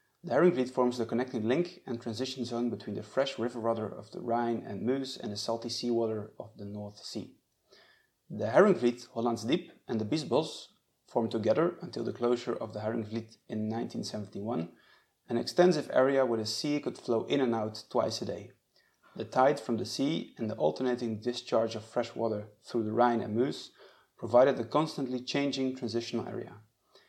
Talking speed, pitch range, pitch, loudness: 180 wpm, 115-130 Hz, 120 Hz, -31 LUFS